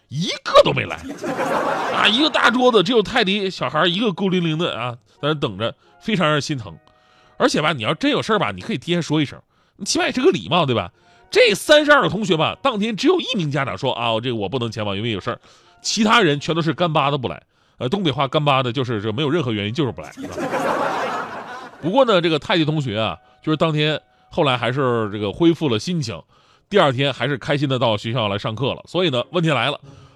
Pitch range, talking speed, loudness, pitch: 125-180 Hz, 340 characters per minute, -19 LUFS, 150 Hz